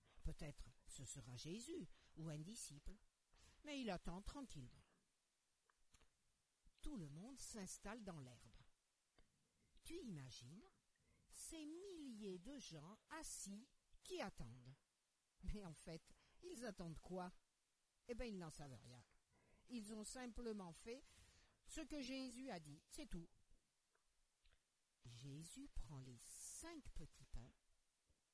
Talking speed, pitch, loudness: 115 wpm, 185 Hz, -56 LUFS